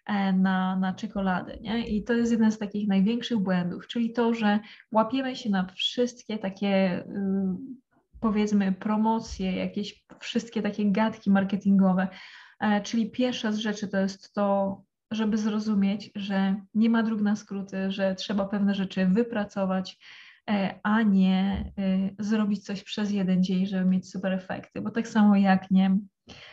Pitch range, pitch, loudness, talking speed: 190-220 Hz, 205 Hz, -27 LUFS, 145 wpm